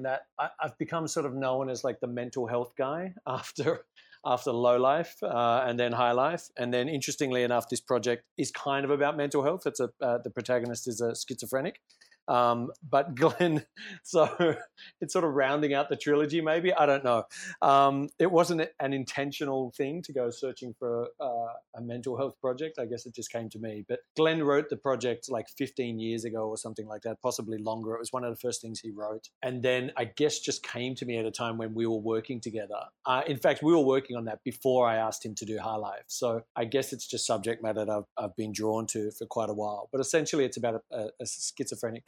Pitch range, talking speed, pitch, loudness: 115-145 Hz, 225 wpm, 125 Hz, -30 LUFS